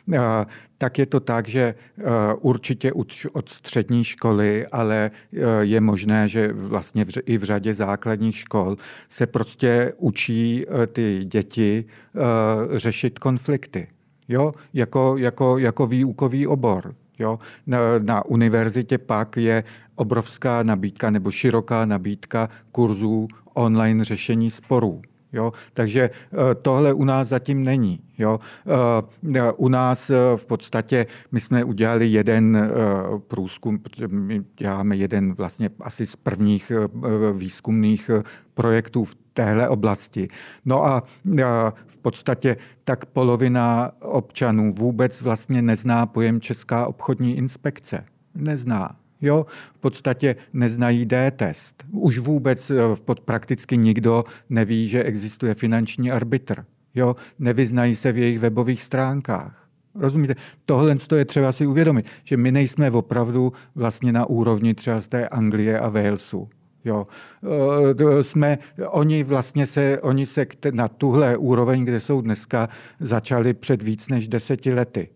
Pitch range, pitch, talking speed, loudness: 110-130 Hz, 120 Hz, 120 wpm, -21 LUFS